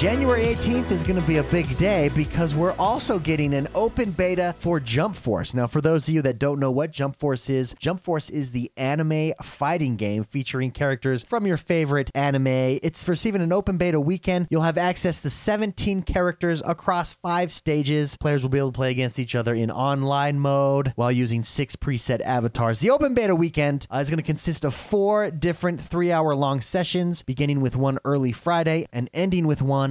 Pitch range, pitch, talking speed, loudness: 135-175 Hz, 150 Hz, 200 wpm, -23 LUFS